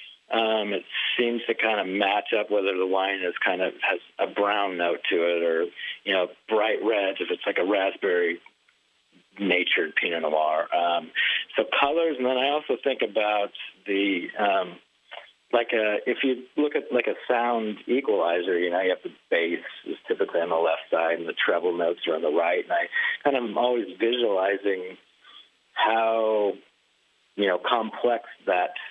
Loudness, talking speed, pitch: -25 LUFS, 180 wpm, 120 Hz